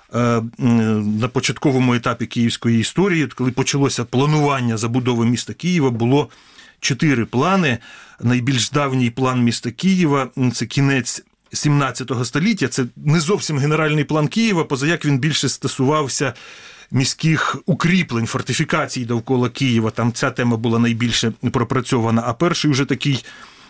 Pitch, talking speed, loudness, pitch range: 130 Hz, 120 wpm, -18 LUFS, 120-150 Hz